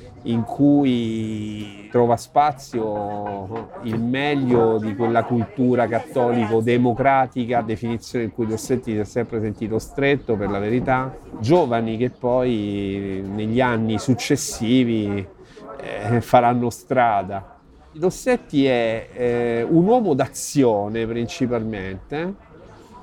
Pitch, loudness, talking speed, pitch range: 120 Hz, -21 LUFS, 100 wpm, 110-125 Hz